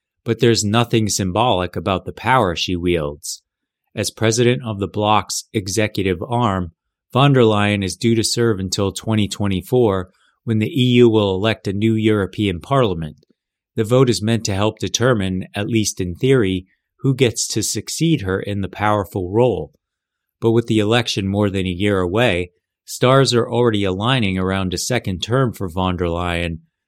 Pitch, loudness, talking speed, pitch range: 105 Hz, -18 LUFS, 165 wpm, 95-120 Hz